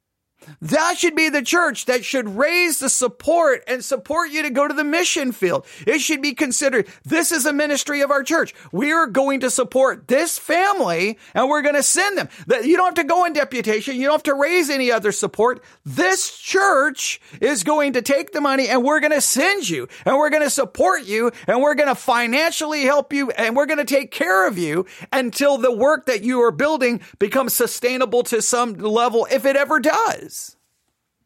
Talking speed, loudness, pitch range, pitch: 210 wpm, -18 LUFS, 245-305 Hz, 280 Hz